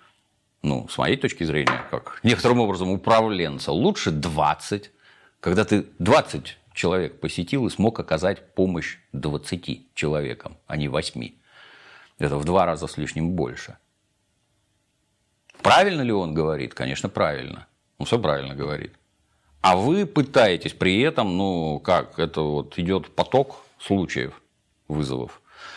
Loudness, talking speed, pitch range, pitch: -23 LUFS, 130 wpm, 75-105 Hz, 85 Hz